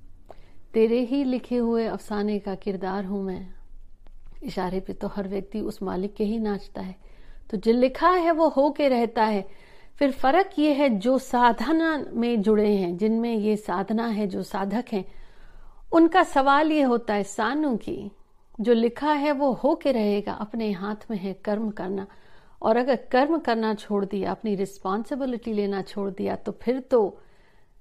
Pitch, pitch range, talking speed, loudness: 220 Hz, 200-260 Hz, 170 wpm, -25 LUFS